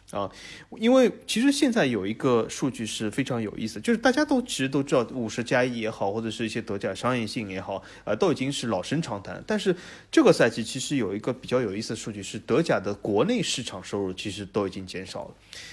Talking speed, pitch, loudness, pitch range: 350 characters per minute, 120 Hz, -26 LUFS, 105-145 Hz